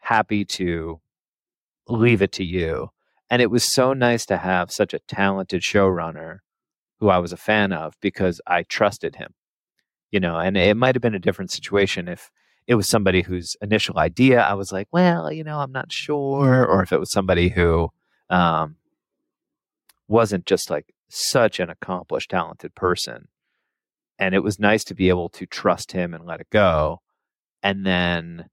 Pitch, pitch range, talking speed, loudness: 100 Hz, 90-115 Hz, 175 wpm, -21 LUFS